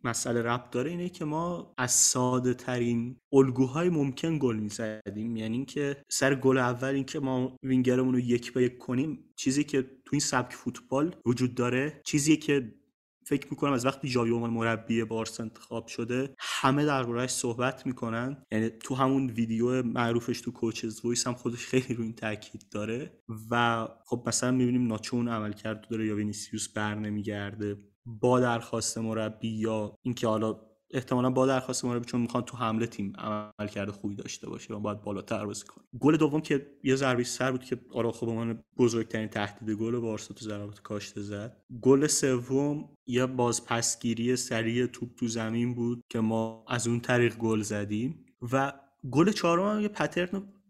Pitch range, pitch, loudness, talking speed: 110-130 Hz, 120 Hz, -29 LUFS, 170 wpm